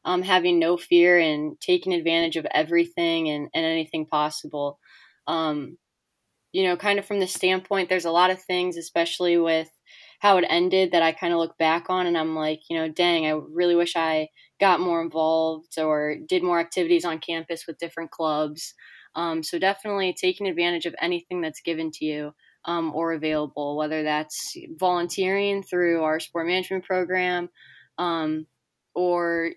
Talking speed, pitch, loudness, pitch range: 170 wpm, 170 Hz, -24 LUFS, 160-180 Hz